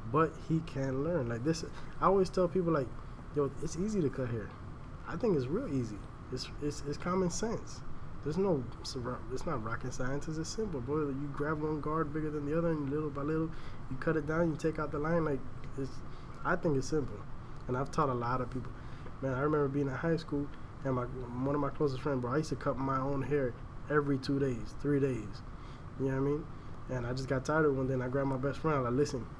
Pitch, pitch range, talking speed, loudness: 140 Hz, 125-155 Hz, 245 wpm, -34 LUFS